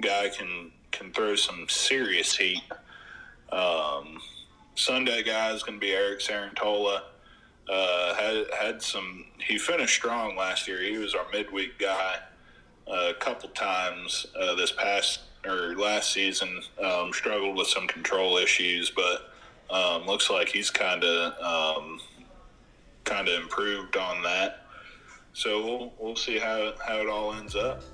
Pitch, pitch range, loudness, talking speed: 100 Hz, 90-110 Hz, -27 LUFS, 145 wpm